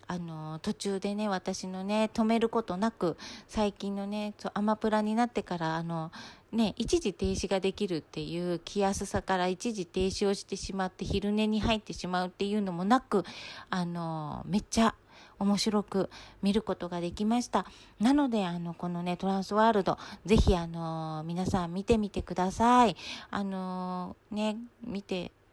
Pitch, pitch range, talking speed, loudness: 195 Hz, 180-215 Hz, 310 characters per minute, -31 LUFS